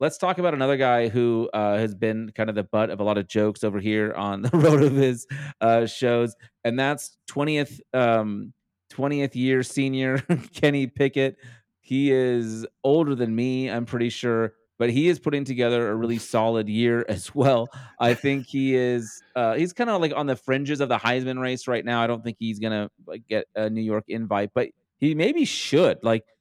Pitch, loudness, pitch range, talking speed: 120 Hz, -24 LUFS, 110-135 Hz, 205 wpm